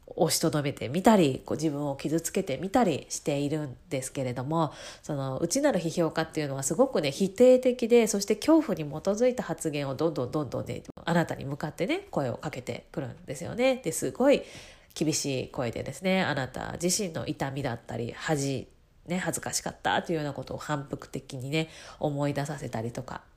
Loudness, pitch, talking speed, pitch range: -29 LUFS, 160 Hz, 395 characters per minute, 140-180 Hz